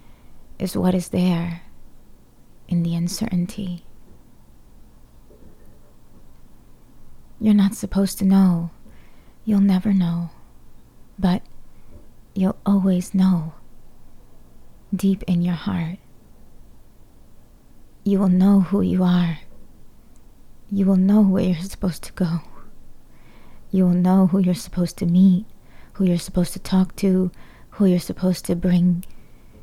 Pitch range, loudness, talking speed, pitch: 175-195 Hz, -20 LUFS, 115 wpm, 185 Hz